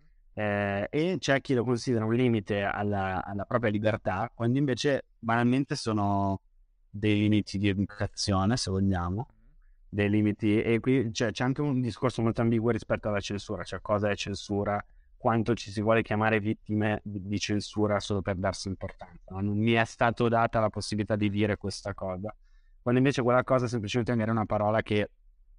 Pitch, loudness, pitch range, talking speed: 105 Hz, -28 LUFS, 100-120 Hz, 175 wpm